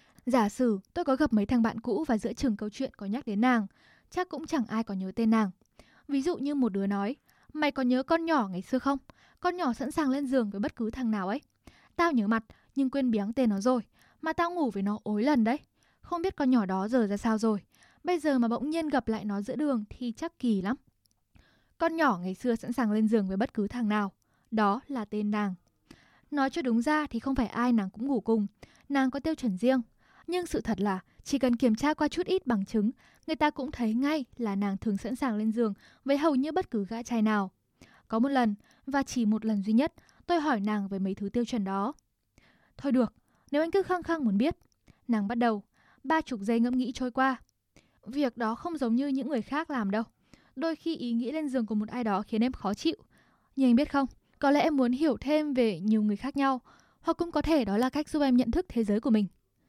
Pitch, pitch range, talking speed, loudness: 245 Hz, 220-285 Hz, 250 wpm, -29 LUFS